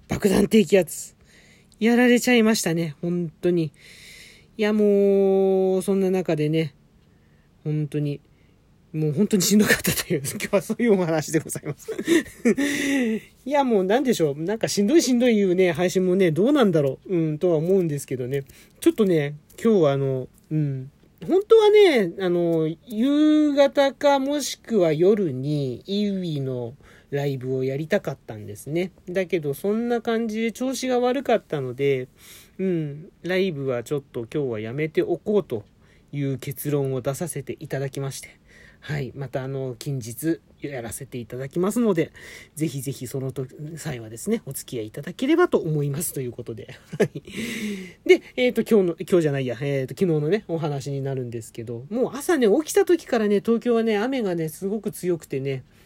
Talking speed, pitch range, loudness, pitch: 345 characters per minute, 140-215 Hz, -23 LUFS, 175 Hz